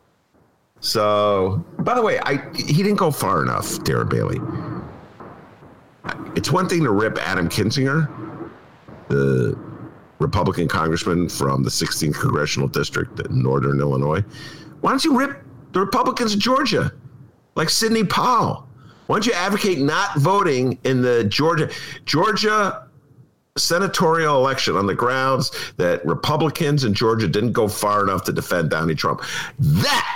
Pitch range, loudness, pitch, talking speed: 105-170 Hz, -20 LUFS, 135 Hz, 135 wpm